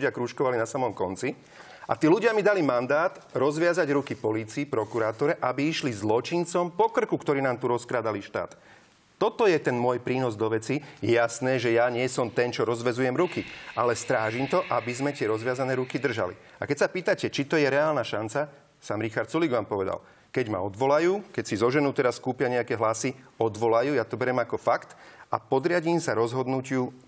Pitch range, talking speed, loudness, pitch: 120-150 Hz, 185 wpm, -26 LUFS, 130 Hz